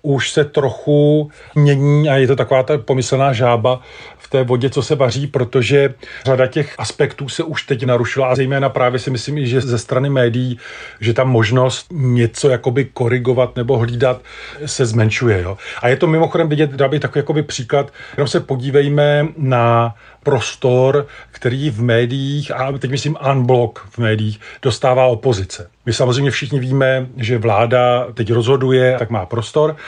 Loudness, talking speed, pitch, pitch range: -16 LUFS, 165 wpm, 130 Hz, 125-140 Hz